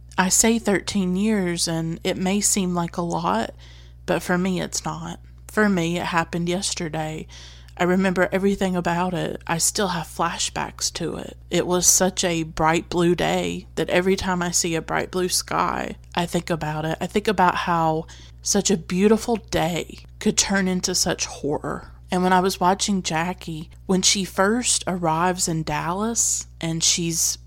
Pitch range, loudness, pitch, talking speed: 165-190 Hz, -22 LUFS, 175 Hz, 175 wpm